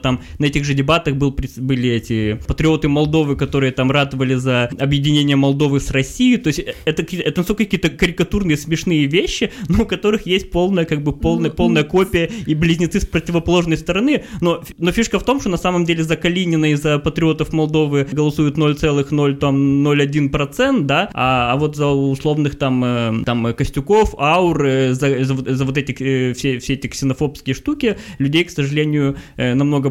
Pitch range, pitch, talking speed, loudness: 135-170 Hz, 150 Hz, 170 wpm, -17 LUFS